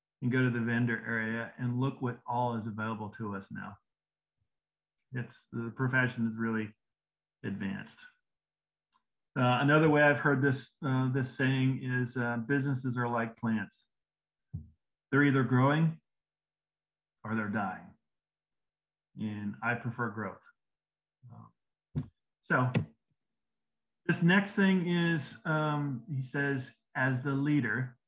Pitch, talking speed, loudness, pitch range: 130 Hz, 120 wpm, -31 LUFS, 115-140 Hz